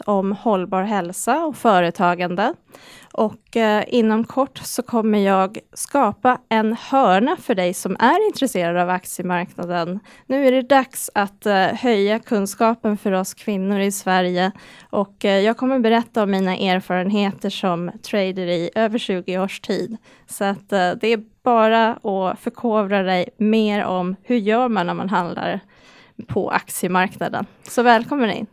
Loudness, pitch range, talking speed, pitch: -20 LUFS, 185-230 Hz, 150 wpm, 205 Hz